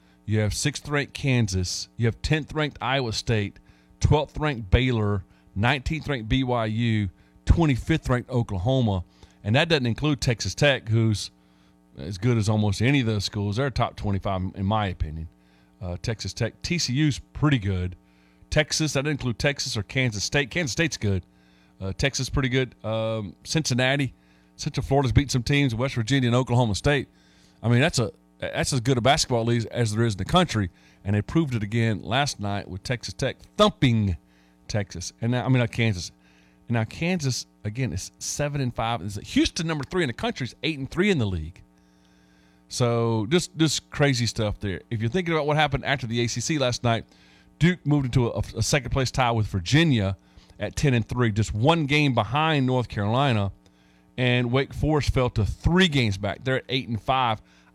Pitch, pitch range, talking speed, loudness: 115 Hz, 100-140 Hz, 185 wpm, -25 LUFS